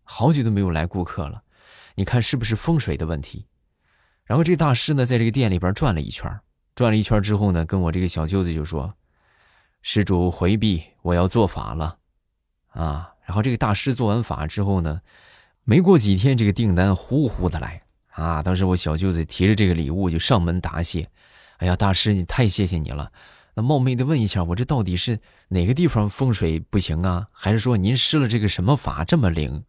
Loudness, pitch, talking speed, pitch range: -21 LUFS, 95 Hz, 300 characters per minute, 85-115 Hz